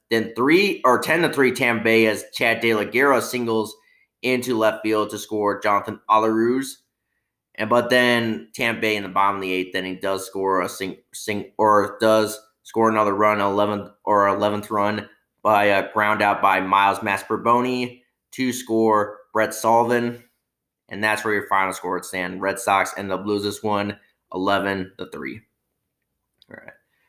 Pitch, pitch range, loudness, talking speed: 105 Hz, 100-115 Hz, -21 LUFS, 175 wpm